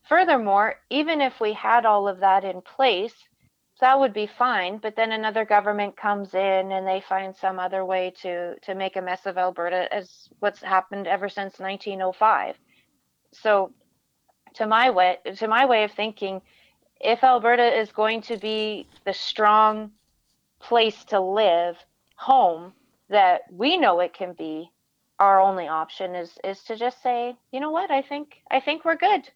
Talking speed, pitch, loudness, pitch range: 170 wpm, 210 Hz, -23 LUFS, 190-240 Hz